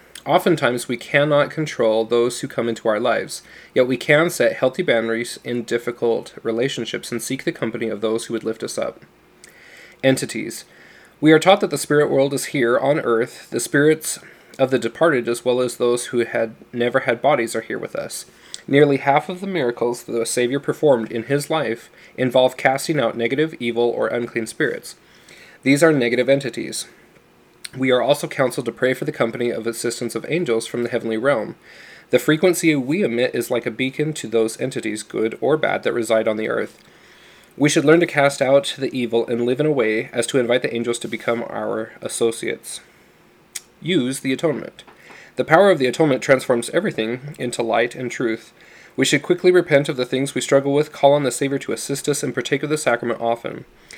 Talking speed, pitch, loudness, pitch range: 200 wpm, 130 Hz, -20 LUFS, 120-145 Hz